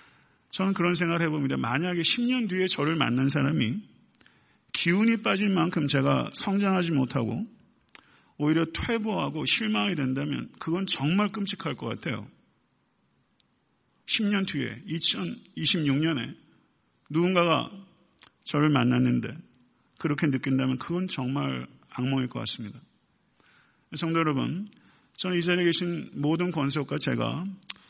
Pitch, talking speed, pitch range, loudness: 165 Hz, 255 characters per minute, 140-190 Hz, -27 LUFS